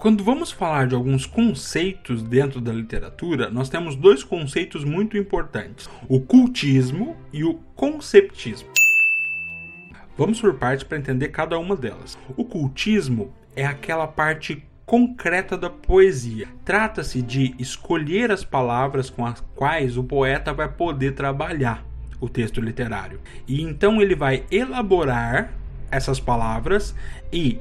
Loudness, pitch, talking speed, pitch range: -21 LUFS, 140 Hz, 130 wpm, 125-185 Hz